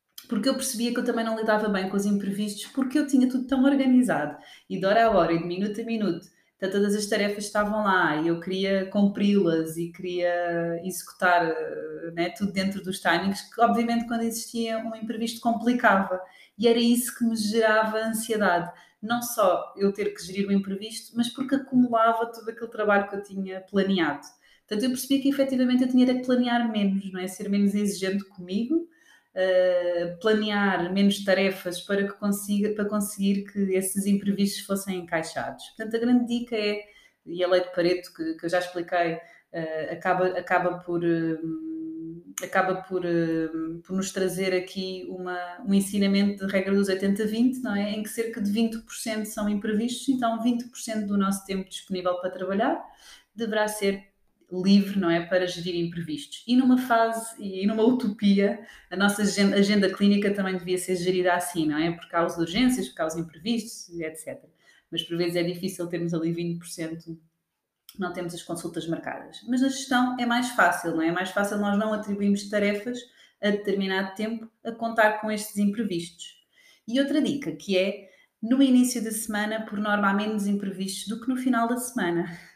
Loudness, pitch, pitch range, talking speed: -26 LUFS, 200 Hz, 180-225 Hz, 180 wpm